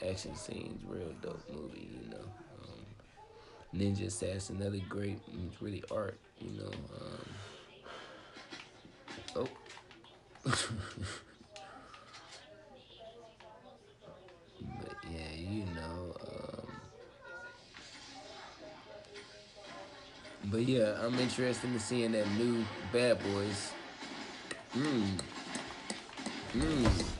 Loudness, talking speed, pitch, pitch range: -38 LUFS, 80 wpm, 105 Hz, 95-120 Hz